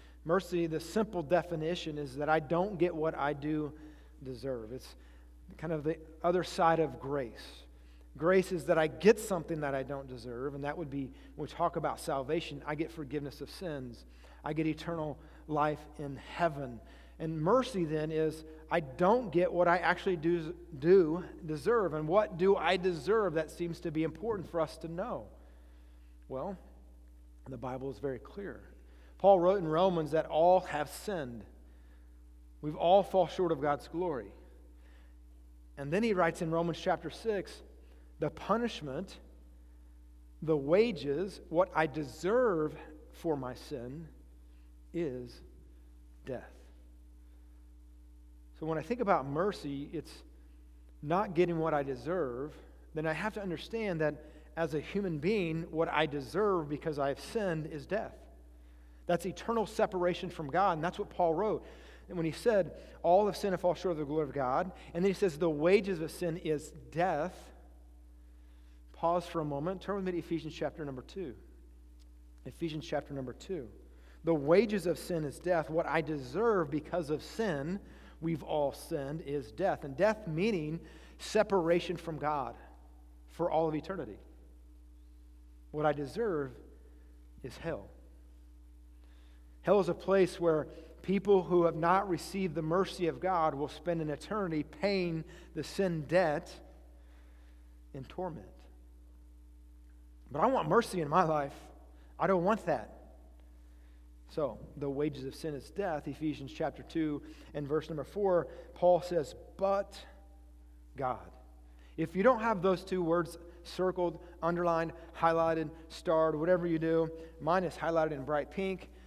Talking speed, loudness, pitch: 155 wpm, -33 LUFS, 155 Hz